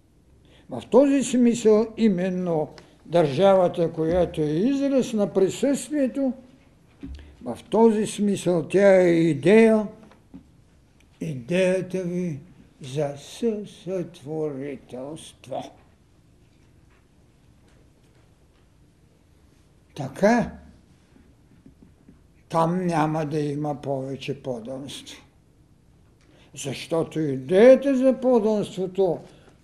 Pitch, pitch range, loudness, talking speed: 175 Hz, 150-215 Hz, -22 LUFS, 65 wpm